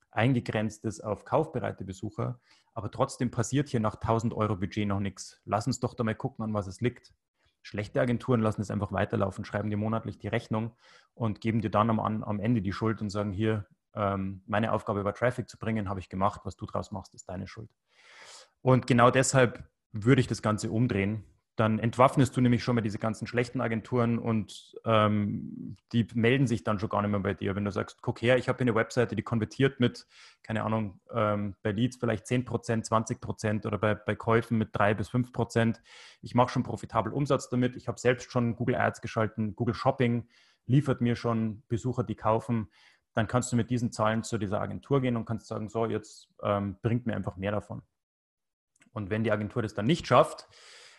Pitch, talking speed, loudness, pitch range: 110 Hz, 200 wpm, -29 LUFS, 105-120 Hz